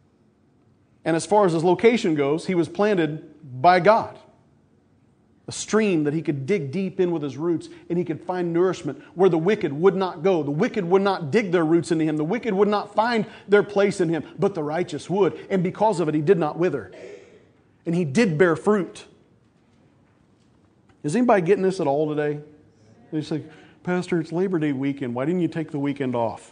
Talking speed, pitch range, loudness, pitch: 205 wpm, 155-195 Hz, -22 LUFS, 170 Hz